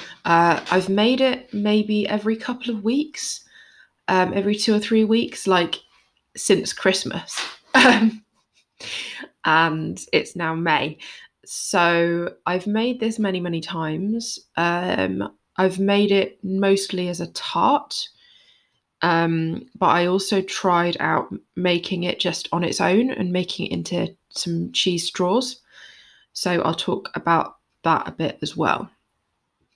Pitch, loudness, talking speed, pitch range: 190 Hz, -21 LUFS, 130 wpm, 170-220 Hz